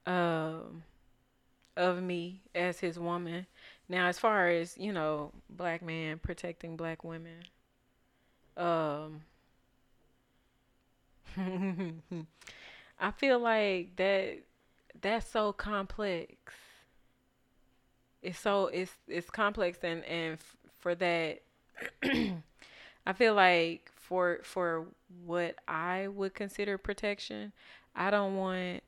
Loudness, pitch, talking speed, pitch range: -33 LUFS, 180 Hz, 100 wpm, 165-195 Hz